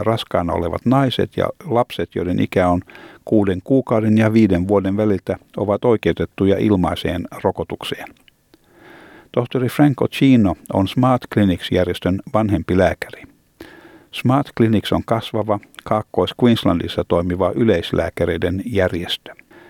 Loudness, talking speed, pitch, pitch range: -18 LUFS, 105 wpm, 105 Hz, 90-115 Hz